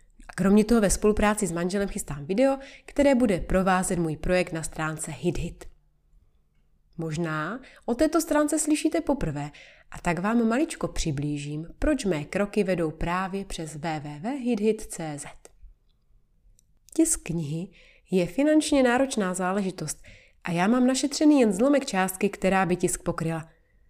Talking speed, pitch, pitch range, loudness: 130 wpm, 185 Hz, 165-250 Hz, -26 LUFS